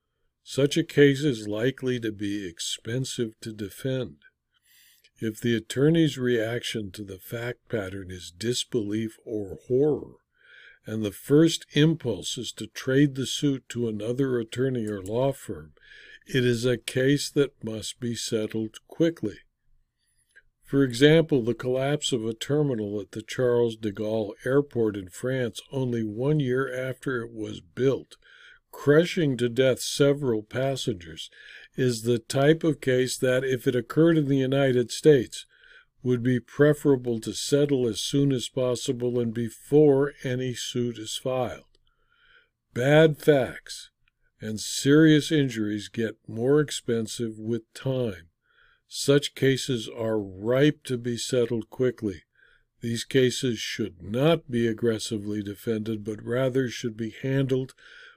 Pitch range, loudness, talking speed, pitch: 110-140 Hz, -26 LUFS, 135 wpm, 125 Hz